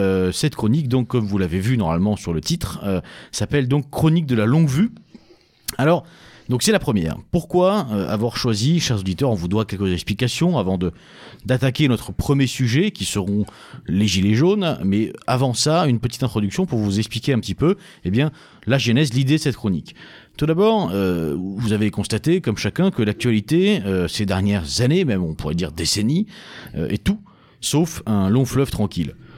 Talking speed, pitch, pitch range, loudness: 190 wpm, 120 Hz, 100-155 Hz, -20 LUFS